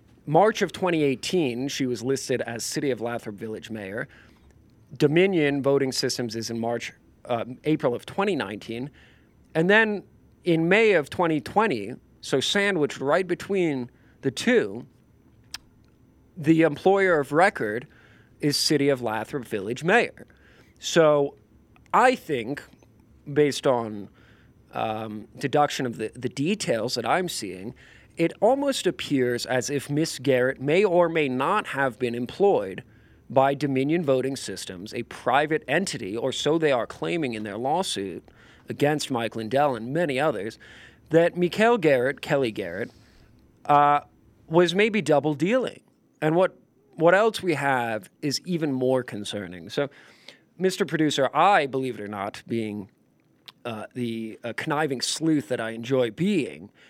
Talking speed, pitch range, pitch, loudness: 140 wpm, 120-160 Hz, 140 Hz, -24 LUFS